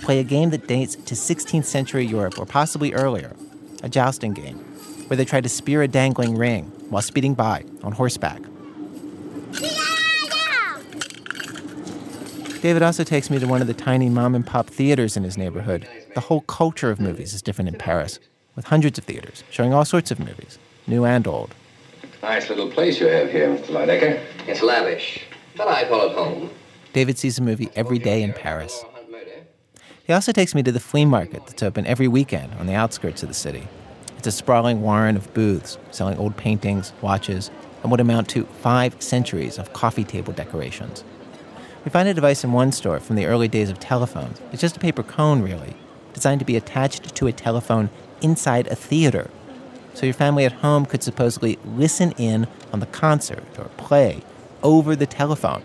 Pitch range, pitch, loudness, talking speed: 110-150 Hz, 125 Hz, -21 LUFS, 185 wpm